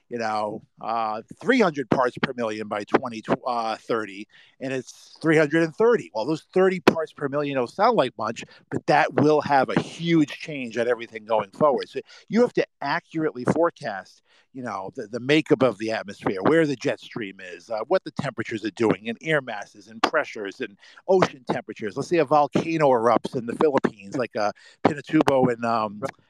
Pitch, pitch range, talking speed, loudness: 135 Hz, 115-160 Hz, 180 wpm, -24 LUFS